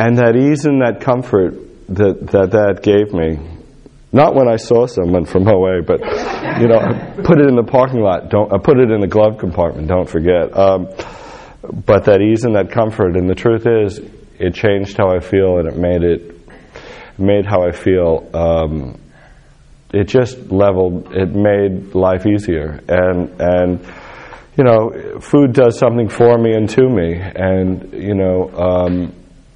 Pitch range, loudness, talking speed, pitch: 90-115 Hz, -14 LUFS, 165 wpm, 95 Hz